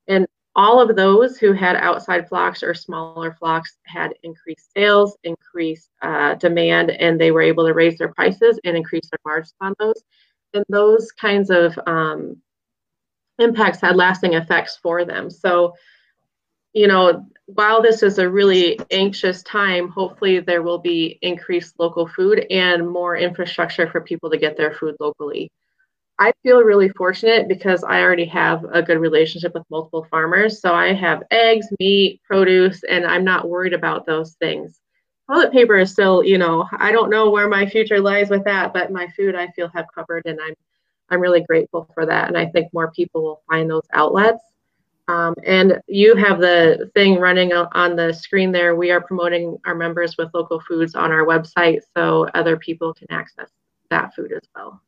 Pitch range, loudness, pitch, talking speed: 165-195 Hz, -17 LUFS, 175 Hz, 180 wpm